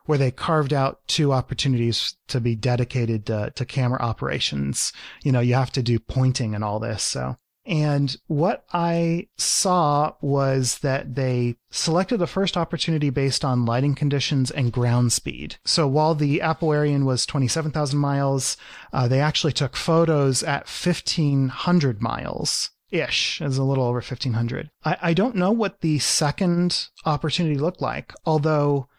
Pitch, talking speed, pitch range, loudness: 140 Hz, 155 wpm, 125-160 Hz, -22 LUFS